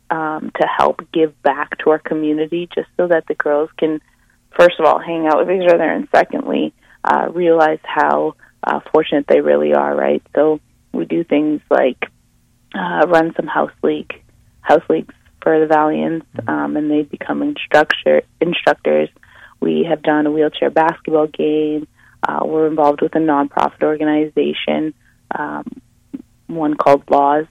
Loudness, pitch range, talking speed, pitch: -16 LUFS, 120-160 Hz, 155 wpm, 150 Hz